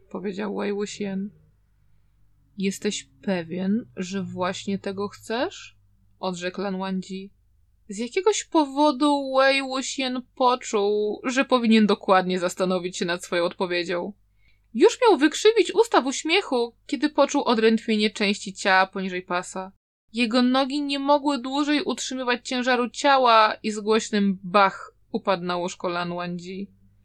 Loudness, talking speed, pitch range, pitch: -23 LUFS, 120 wpm, 185-260 Hz, 205 Hz